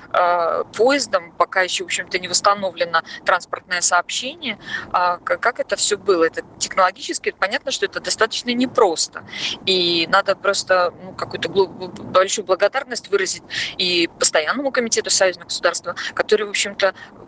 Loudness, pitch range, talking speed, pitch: -19 LUFS, 180-220 Hz, 130 wpm, 190 Hz